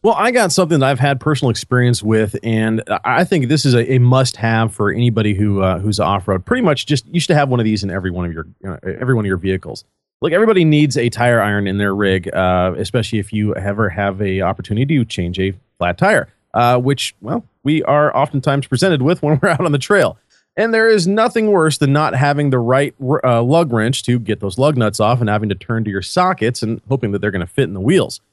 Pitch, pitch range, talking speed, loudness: 120 Hz, 105-145 Hz, 250 wpm, -16 LUFS